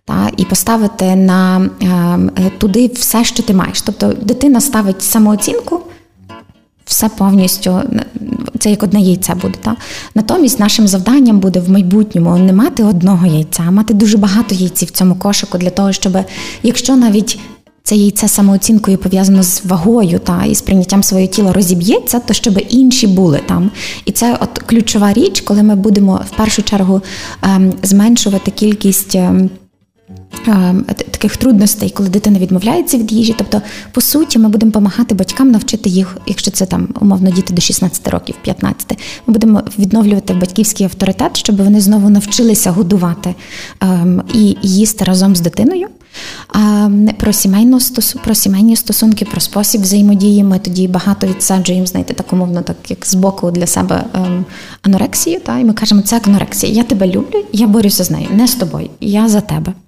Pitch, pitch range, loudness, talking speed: 205 Hz, 190-220 Hz, -11 LUFS, 160 wpm